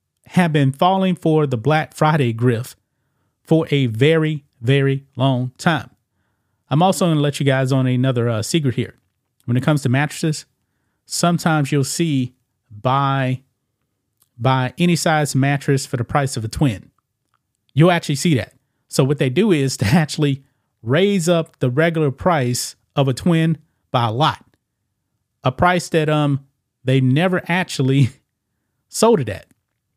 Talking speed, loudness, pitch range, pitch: 155 wpm, -18 LUFS, 125-155 Hz, 135 Hz